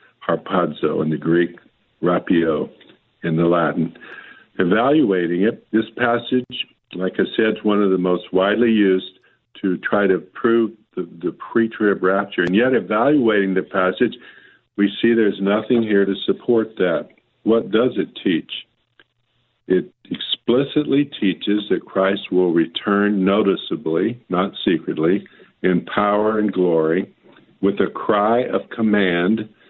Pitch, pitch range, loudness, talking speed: 100 Hz, 95-115 Hz, -19 LUFS, 135 wpm